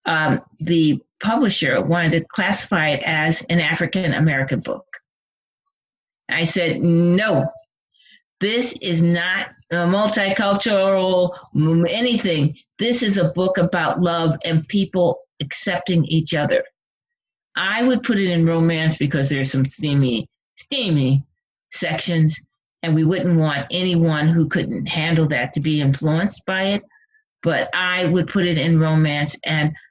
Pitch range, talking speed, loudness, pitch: 155-190 Hz, 130 wpm, -19 LUFS, 170 Hz